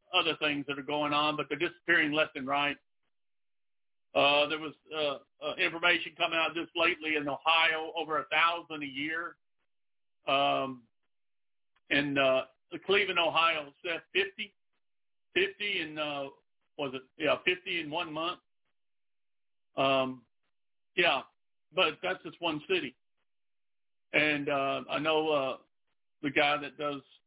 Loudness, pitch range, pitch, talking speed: -30 LUFS, 145-165 Hz, 150 Hz, 135 wpm